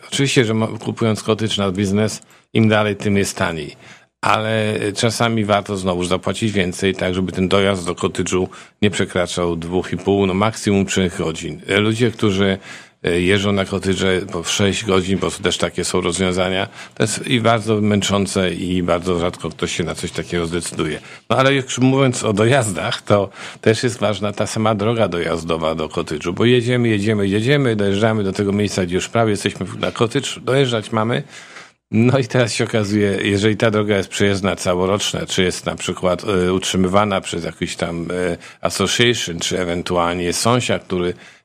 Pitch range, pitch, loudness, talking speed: 90-110 Hz, 100 Hz, -18 LUFS, 165 wpm